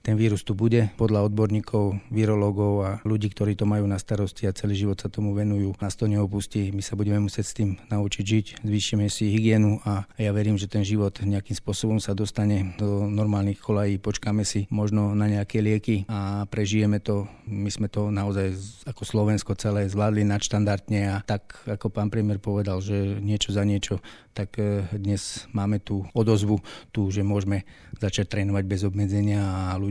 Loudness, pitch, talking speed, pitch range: -25 LUFS, 105 Hz, 180 wpm, 100-105 Hz